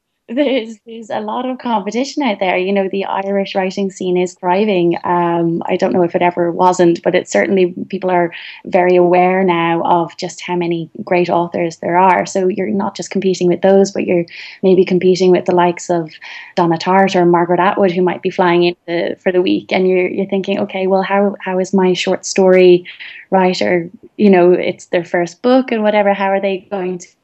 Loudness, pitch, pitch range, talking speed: -14 LUFS, 185 Hz, 175-195 Hz, 210 wpm